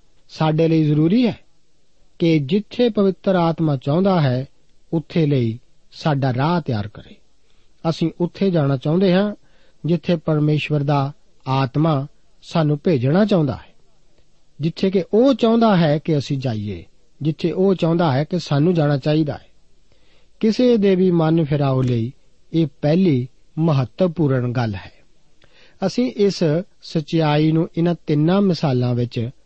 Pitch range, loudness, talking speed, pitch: 140-180 Hz, -19 LUFS, 130 wpm, 160 Hz